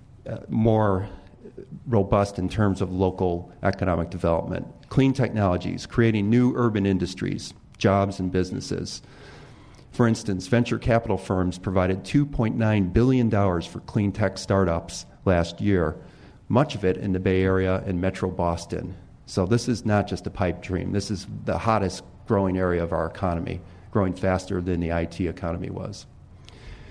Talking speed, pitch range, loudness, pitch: 145 wpm, 90-115 Hz, -24 LUFS, 95 Hz